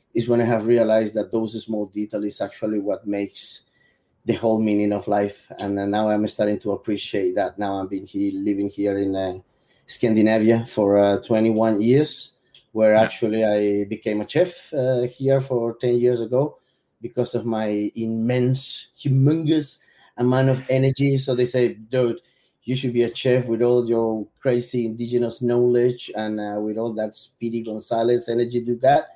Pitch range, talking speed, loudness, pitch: 105-125 Hz, 175 wpm, -22 LUFS, 115 Hz